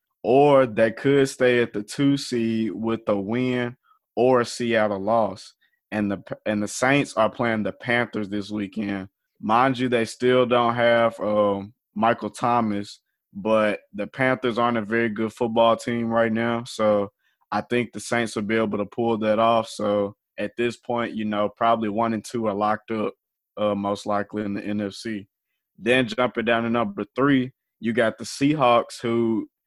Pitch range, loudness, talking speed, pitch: 105-120 Hz, -23 LUFS, 180 wpm, 115 Hz